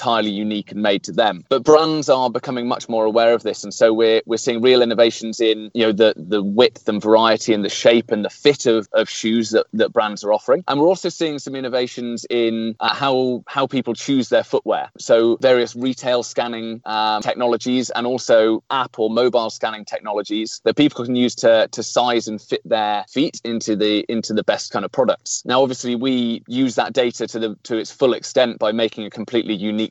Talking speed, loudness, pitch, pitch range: 215 wpm, -18 LUFS, 115 Hz, 110-125 Hz